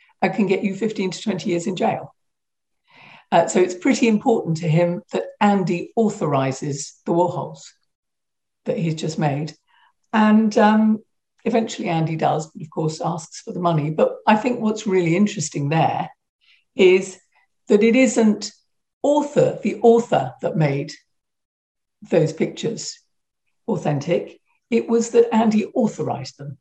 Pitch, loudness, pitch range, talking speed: 195 Hz, -20 LUFS, 165-225 Hz, 140 wpm